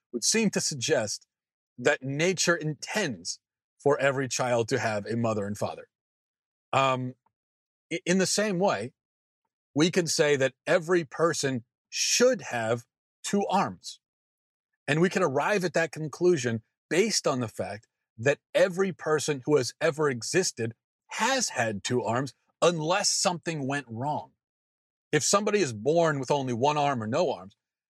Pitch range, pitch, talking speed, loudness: 125-180 Hz, 150 Hz, 145 wpm, -27 LUFS